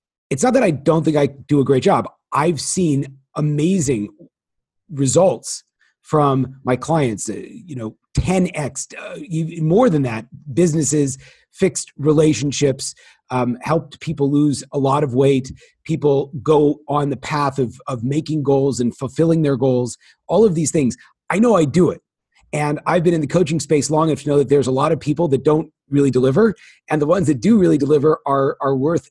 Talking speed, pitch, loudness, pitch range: 185 wpm, 145 Hz, -18 LUFS, 135-160 Hz